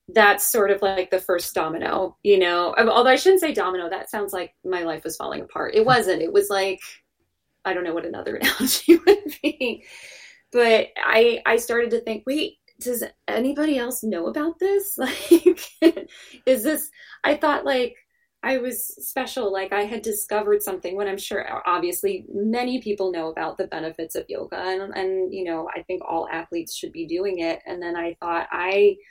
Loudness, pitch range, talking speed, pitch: -22 LUFS, 185-300 Hz, 190 wpm, 225 Hz